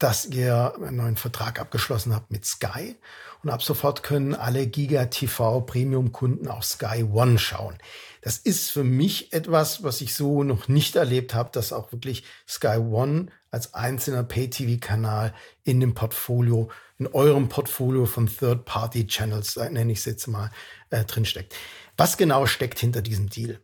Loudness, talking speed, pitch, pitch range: -24 LUFS, 160 wpm, 120 Hz, 115-135 Hz